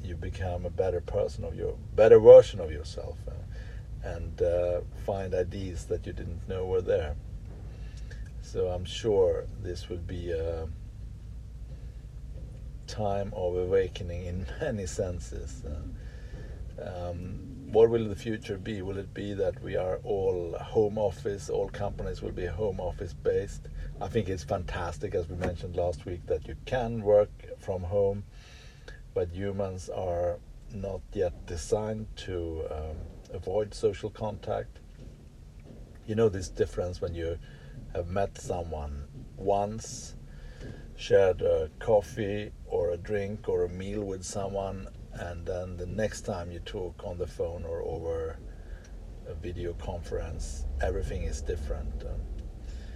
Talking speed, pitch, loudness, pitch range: 140 wpm, 100 Hz, -30 LUFS, 85-110 Hz